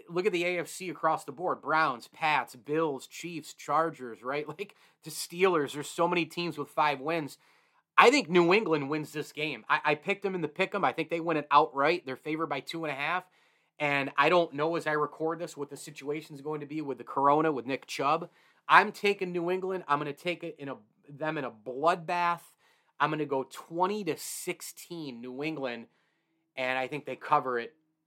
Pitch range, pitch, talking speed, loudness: 145-170 Hz, 155 Hz, 215 wpm, -30 LUFS